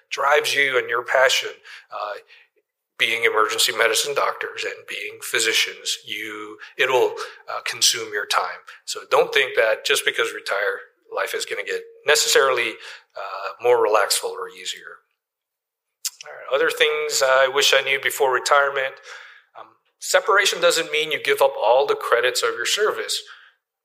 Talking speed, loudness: 150 wpm, -20 LUFS